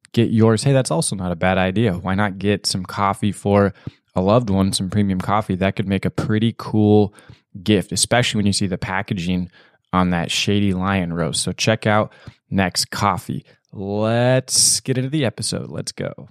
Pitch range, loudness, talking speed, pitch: 95-115 Hz, -19 LUFS, 190 wpm, 105 Hz